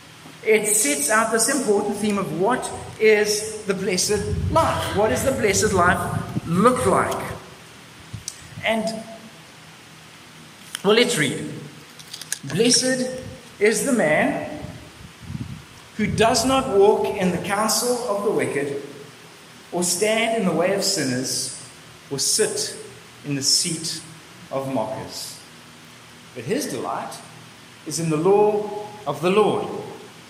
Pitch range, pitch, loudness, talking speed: 145-215 Hz, 200 Hz, -21 LUFS, 120 wpm